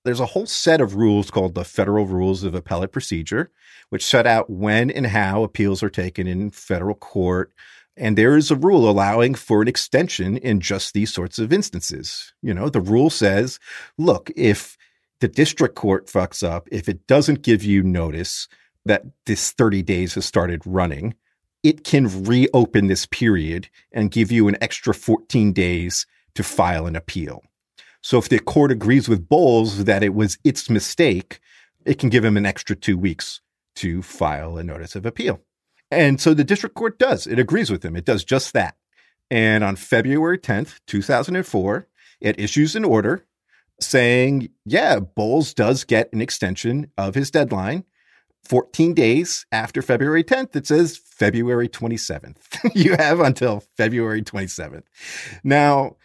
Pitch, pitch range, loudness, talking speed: 110 Hz, 95-135 Hz, -19 LUFS, 165 wpm